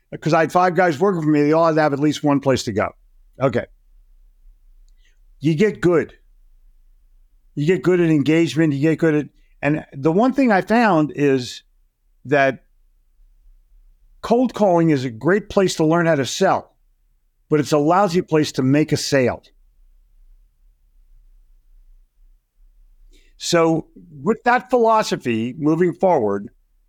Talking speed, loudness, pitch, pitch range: 145 wpm, -18 LUFS, 150 Hz, 120-175 Hz